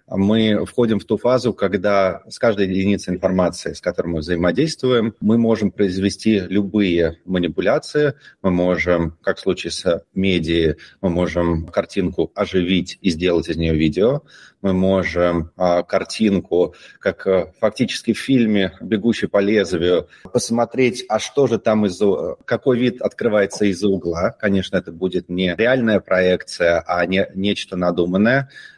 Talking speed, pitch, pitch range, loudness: 140 wpm, 95 Hz, 90-110 Hz, -19 LUFS